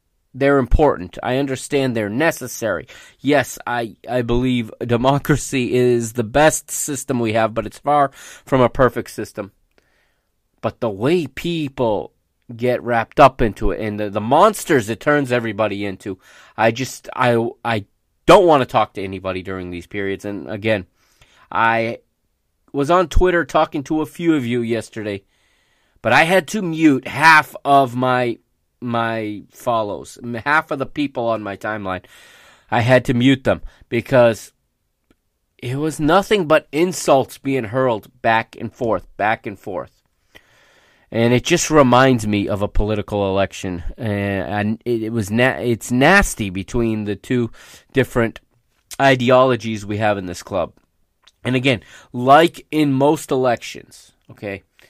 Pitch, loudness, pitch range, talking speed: 120 Hz, -18 LUFS, 110-135 Hz, 145 wpm